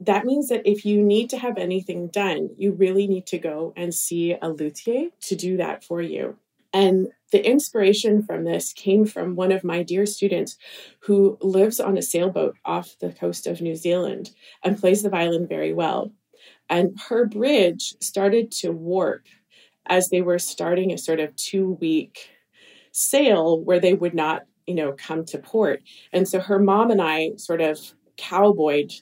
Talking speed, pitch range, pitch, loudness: 180 wpm, 170-205 Hz, 185 Hz, -22 LUFS